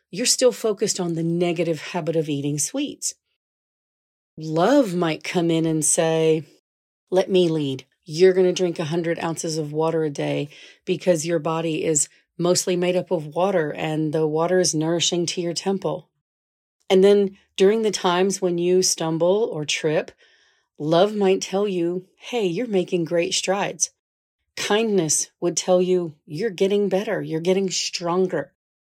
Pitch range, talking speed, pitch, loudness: 160-185 Hz, 155 wpm, 175 Hz, -22 LUFS